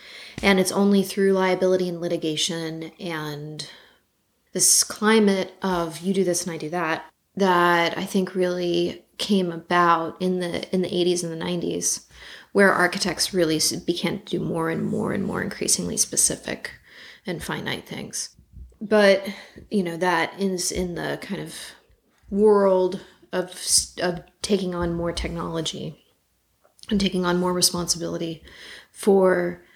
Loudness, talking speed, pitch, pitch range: -22 LUFS, 140 wpm, 180 Hz, 170-190 Hz